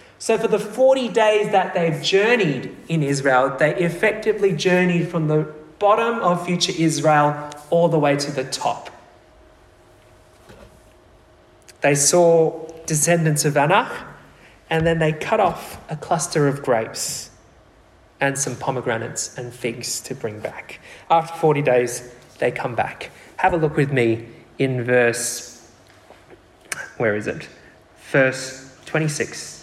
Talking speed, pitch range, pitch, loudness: 130 wpm, 130-170 Hz, 150 Hz, -20 LUFS